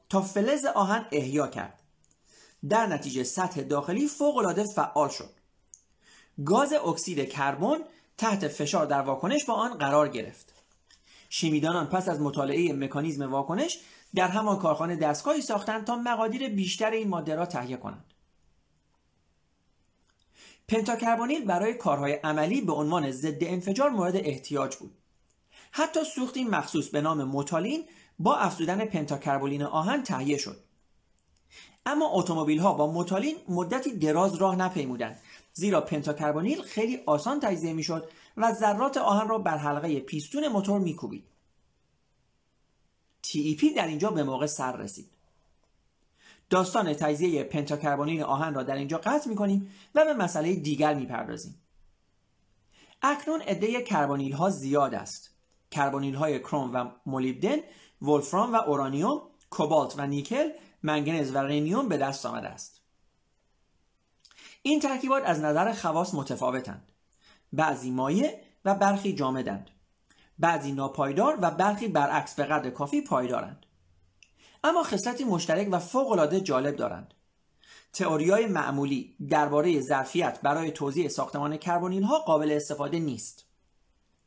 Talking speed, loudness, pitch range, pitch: 125 wpm, -28 LUFS, 140-205 Hz, 155 Hz